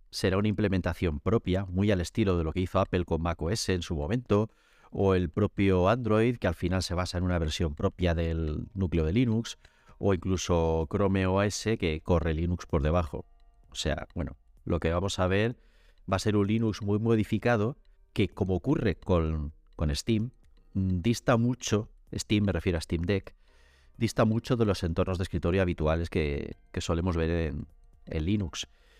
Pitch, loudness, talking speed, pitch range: 95 Hz, -29 LUFS, 180 wpm, 85-105 Hz